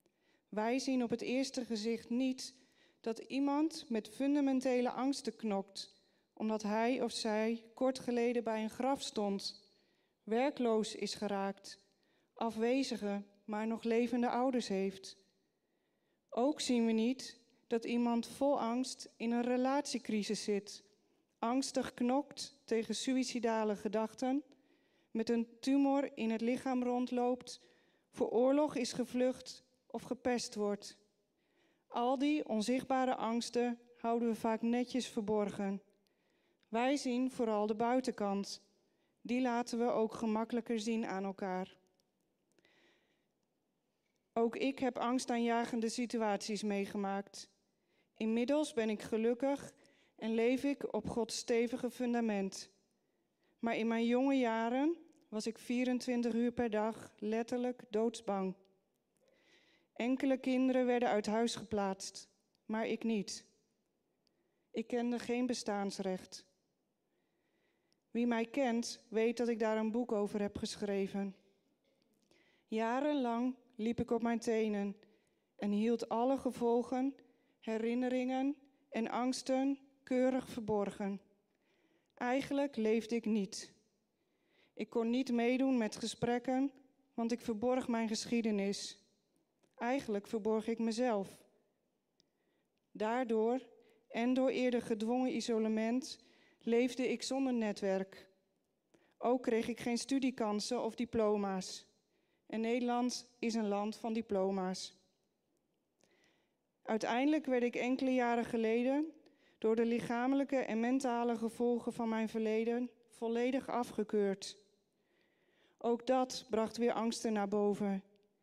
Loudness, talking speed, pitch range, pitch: -36 LUFS, 110 wpm, 215-250 Hz, 235 Hz